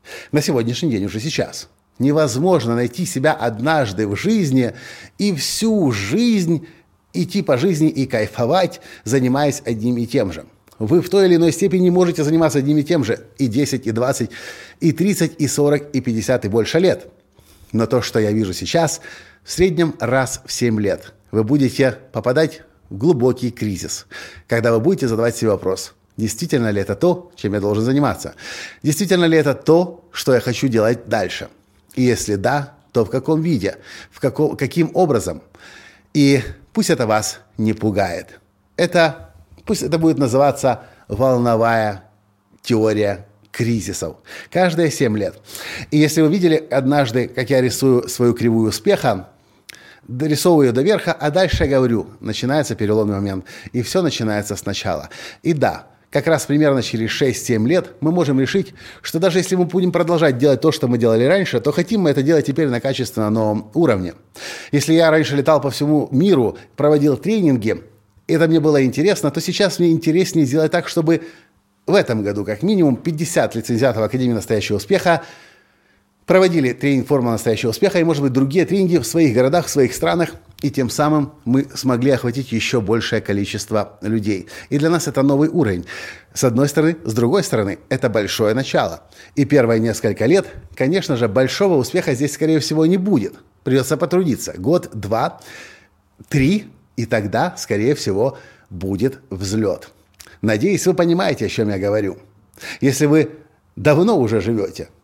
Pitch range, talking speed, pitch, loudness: 110-160 Hz, 165 wpm, 135 Hz, -18 LUFS